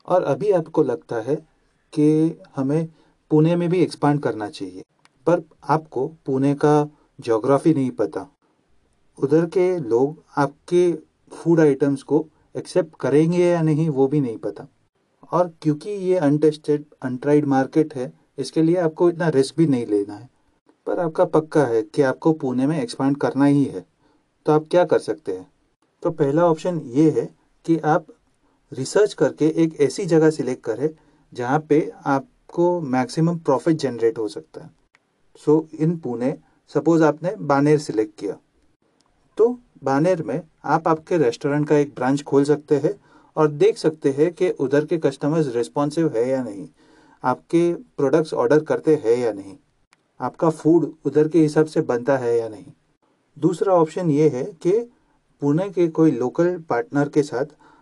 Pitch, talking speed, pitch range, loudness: 150 Hz, 160 wpm, 140-165 Hz, -21 LUFS